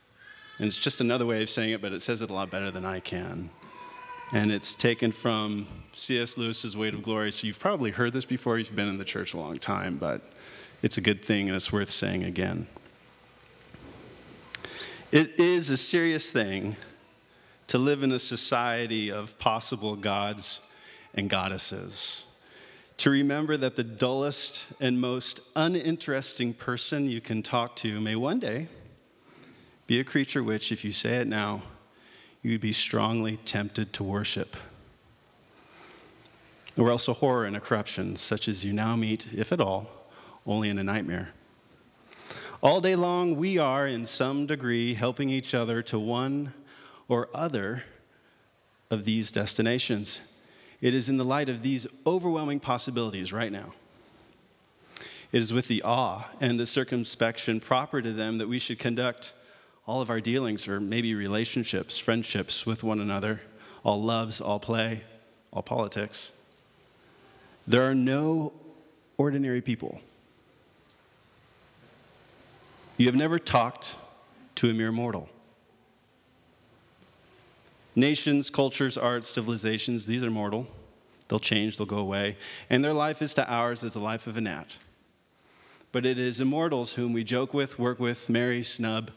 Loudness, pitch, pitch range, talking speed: -28 LUFS, 115 Hz, 110-130 Hz, 155 wpm